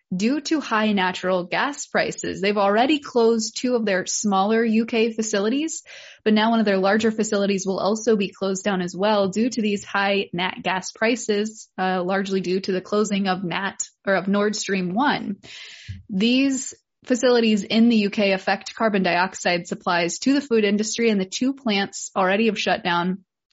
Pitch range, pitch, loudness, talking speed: 190-225 Hz, 205 Hz, -22 LUFS, 180 wpm